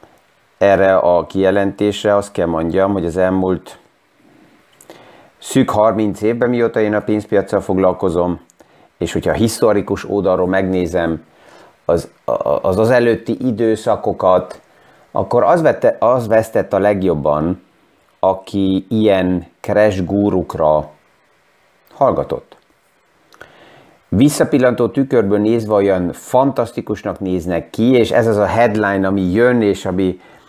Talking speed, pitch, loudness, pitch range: 110 wpm, 100 Hz, -15 LUFS, 95-110 Hz